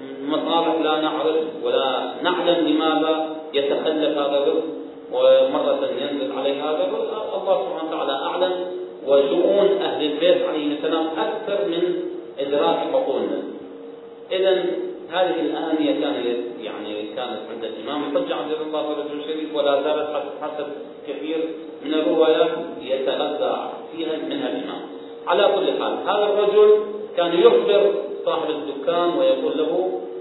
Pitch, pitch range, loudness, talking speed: 160 Hz, 150-185 Hz, -21 LUFS, 125 wpm